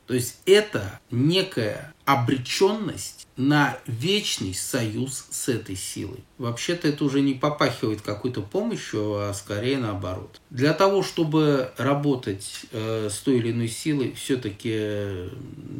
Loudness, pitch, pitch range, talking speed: -25 LUFS, 130 Hz, 105-145 Hz, 125 wpm